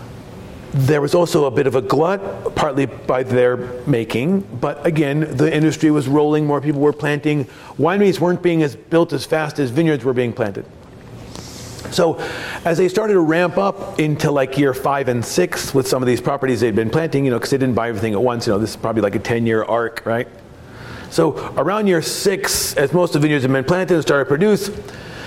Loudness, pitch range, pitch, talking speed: -18 LUFS, 125-165 Hz, 145 Hz, 215 wpm